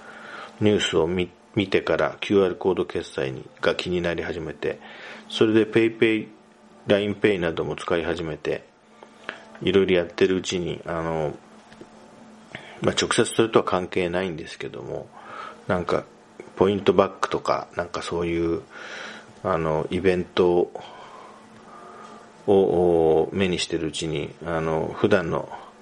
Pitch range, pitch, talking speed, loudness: 80-95 Hz, 90 Hz, 285 characters per minute, -24 LUFS